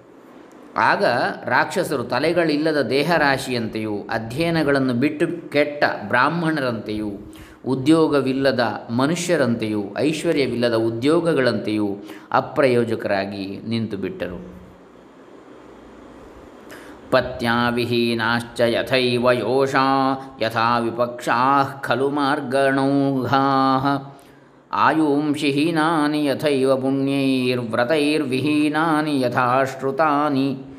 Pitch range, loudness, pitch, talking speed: 120-145 Hz, -20 LUFS, 135 Hz, 50 wpm